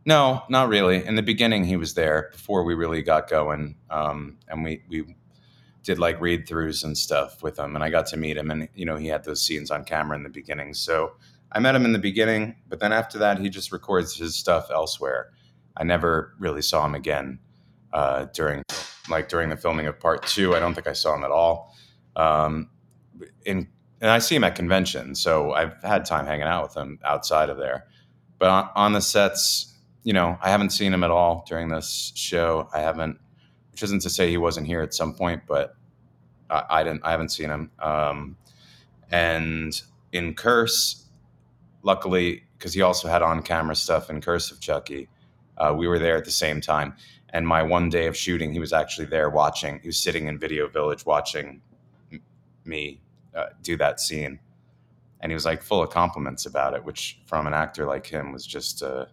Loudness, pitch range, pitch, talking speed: -24 LUFS, 75-90 Hz, 80 Hz, 205 wpm